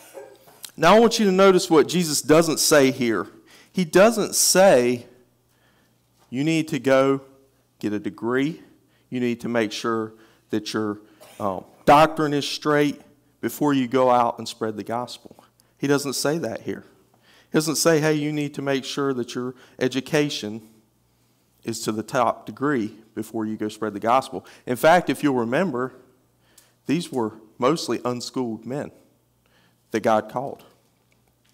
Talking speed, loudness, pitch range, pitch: 155 wpm, -22 LUFS, 115-145 Hz, 130 Hz